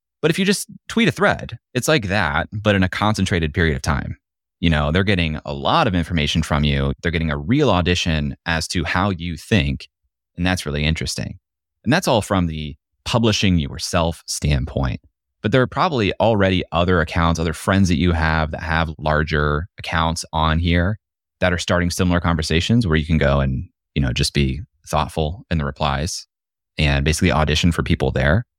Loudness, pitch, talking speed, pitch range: -19 LUFS, 85 Hz, 190 wpm, 75-90 Hz